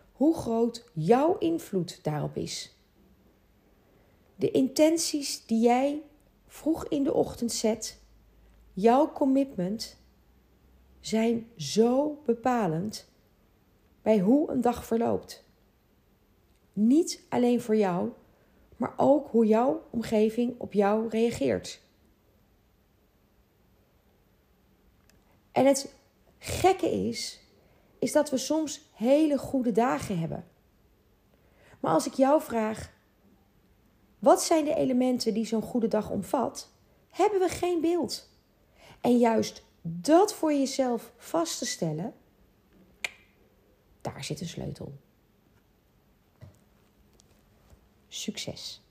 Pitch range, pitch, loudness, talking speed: 215-290 Hz, 240 Hz, -27 LUFS, 100 wpm